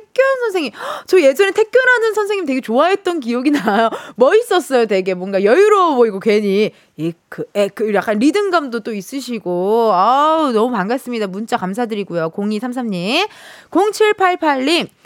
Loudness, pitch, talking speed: -15 LUFS, 255 Hz, 310 characters per minute